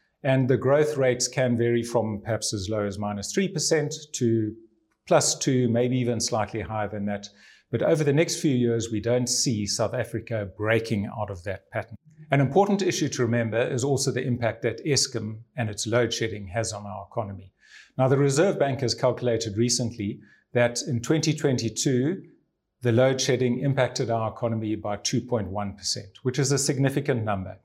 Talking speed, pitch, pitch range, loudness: 175 wpm, 120 Hz, 110-135 Hz, -25 LUFS